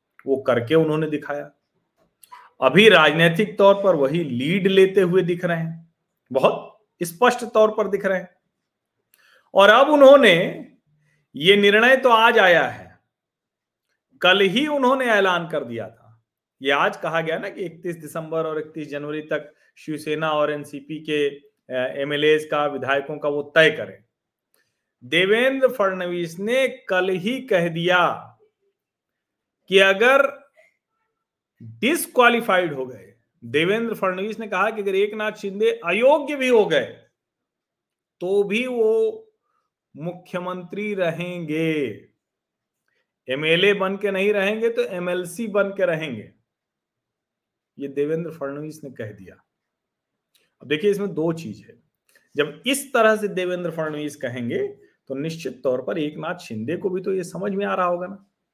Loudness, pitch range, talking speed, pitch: -20 LUFS, 155-215 Hz, 140 wpm, 180 Hz